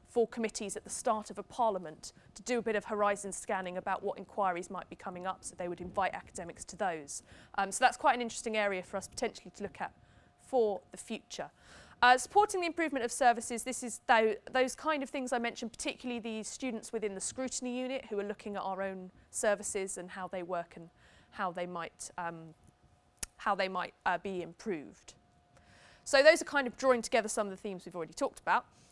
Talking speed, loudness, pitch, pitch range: 215 wpm, -34 LUFS, 210 Hz, 185-245 Hz